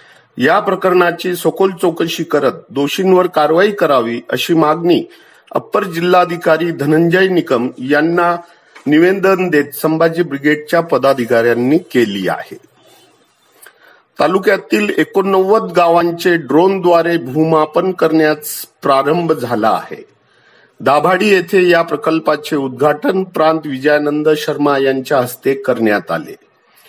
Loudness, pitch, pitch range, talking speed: -13 LUFS, 160 Hz, 145-180 Hz, 95 wpm